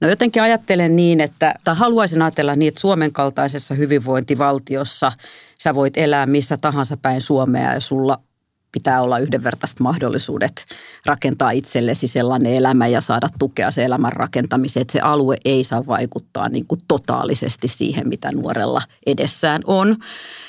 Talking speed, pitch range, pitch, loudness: 145 wpm, 130-155 Hz, 140 Hz, -18 LUFS